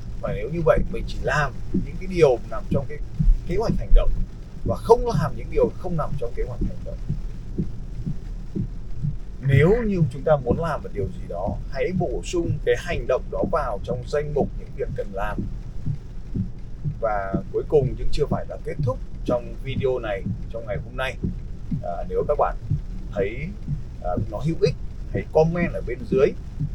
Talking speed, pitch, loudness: 190 wpm, 150 Hz, -25 LUFS